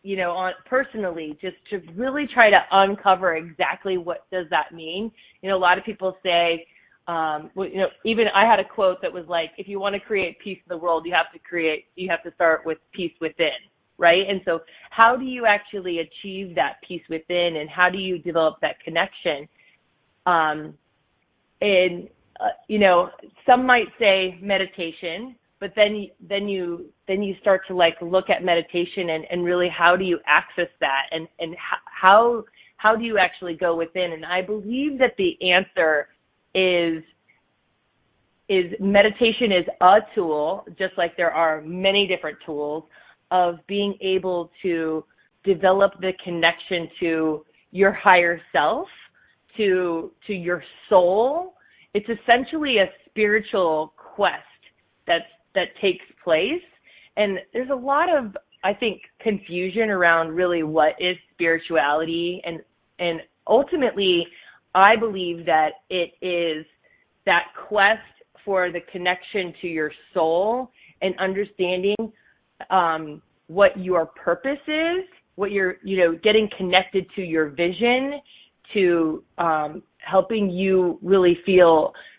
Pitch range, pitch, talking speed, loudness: 170-200 Hz, 185 Hz, 150 wpm, -21 LUFS